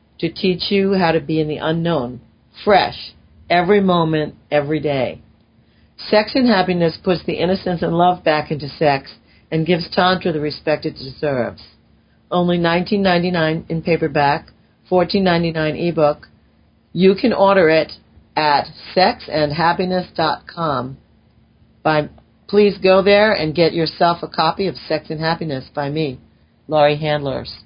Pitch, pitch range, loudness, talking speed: 165 Hz, 150-180 Hz, -17 LUFS, 145 wpm